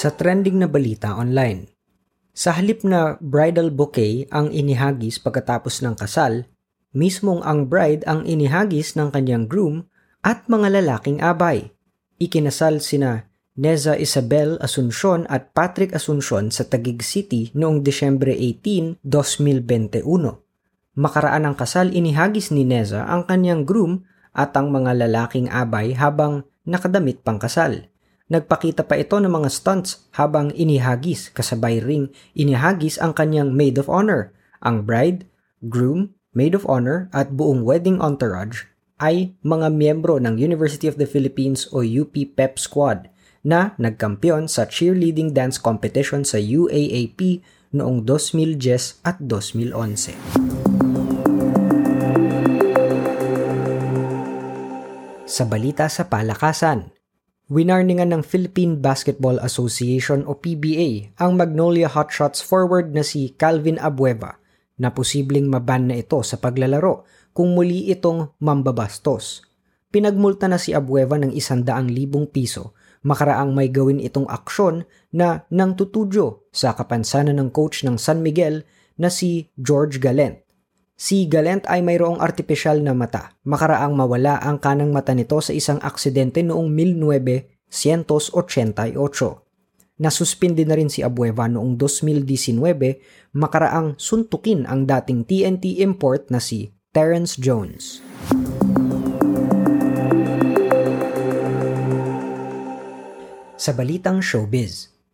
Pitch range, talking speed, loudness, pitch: 125-165 Hz, 120 wpm, -19 LUFS, 145 Hz